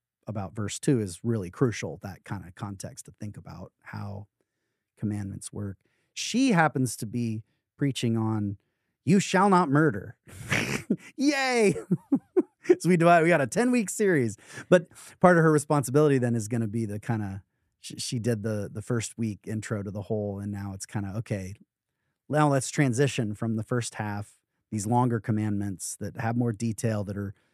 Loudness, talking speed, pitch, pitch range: -27 LUFS, 175 wpm, 115 Hz, 105-150 Hz